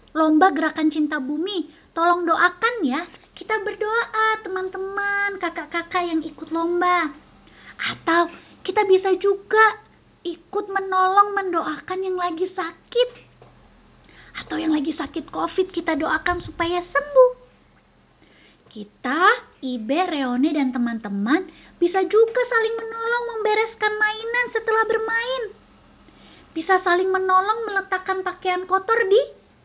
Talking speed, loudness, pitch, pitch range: 105 wpm, -21 LUFS, 370 Hz, 325-430 Hz